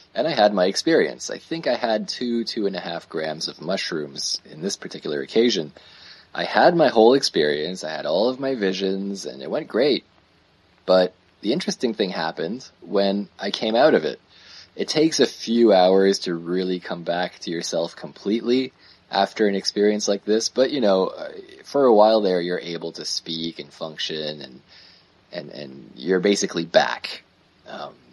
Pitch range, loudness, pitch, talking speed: 90-105 Hz, -22 LUFS, 95 Hz, 180 wpm